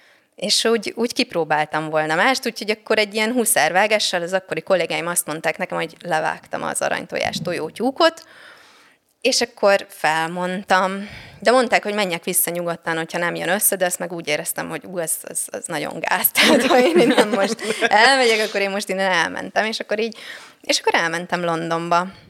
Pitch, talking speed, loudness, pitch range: 190 Hz, 165 wpm, -19 LUFS, 170-225 Hz